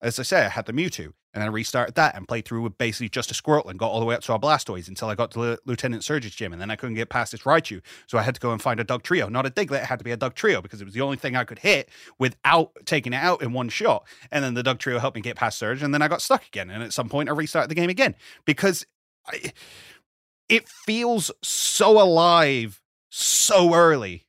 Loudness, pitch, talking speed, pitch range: -23 LUFS, 125 Hz, 280 wpm, 115-150 Hz